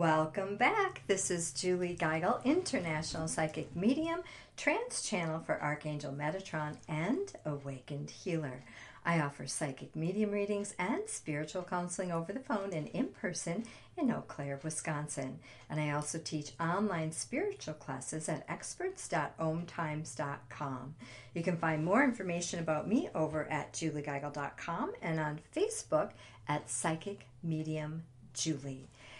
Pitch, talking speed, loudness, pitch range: 160 Hz, 125 wpm, -36 LUFS, 150-190 Hz